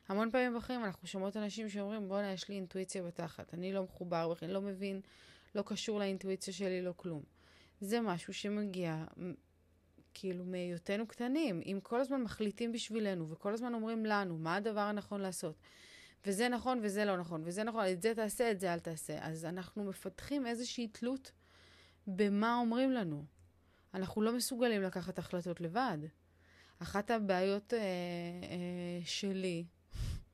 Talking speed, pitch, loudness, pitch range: 150 wpm, 195 Hz, -38 LUFS, 175-220 Hz